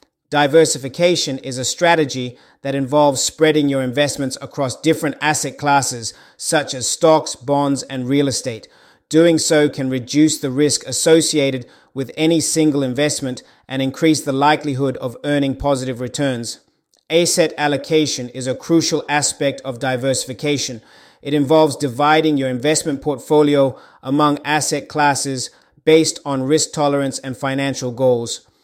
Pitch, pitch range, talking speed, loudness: 140 Hz, 130-150 Hz, 130 wpm, -17 LUFS